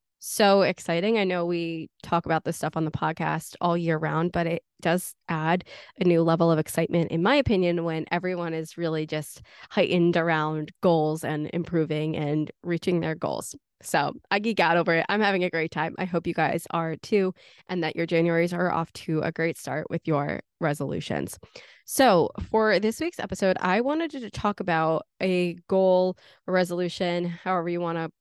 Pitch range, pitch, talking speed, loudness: 160-185 Hz, 170 Hz, 190 wpm, -26 LUFS